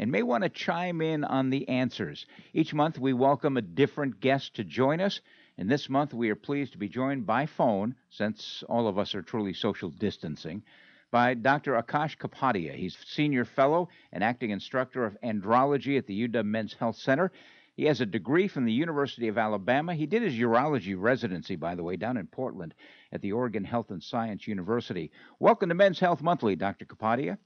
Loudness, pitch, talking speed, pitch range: -29 LUFS, 135 Hz, 200 wpm, 115-150 Hz